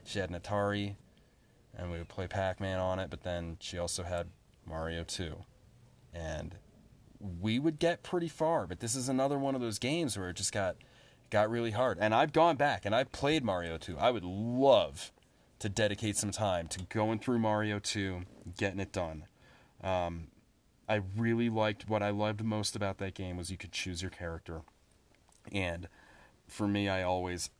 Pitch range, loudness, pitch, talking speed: 90-115 Hz, -34 LUFS, 100 Hz, 185 wpm